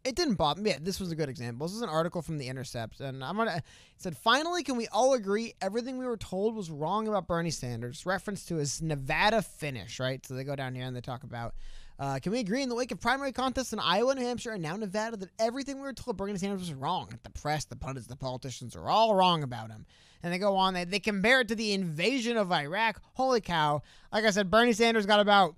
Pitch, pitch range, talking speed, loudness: 190 Hz, 140-225 Hz, 260 wpm, -30 LUFS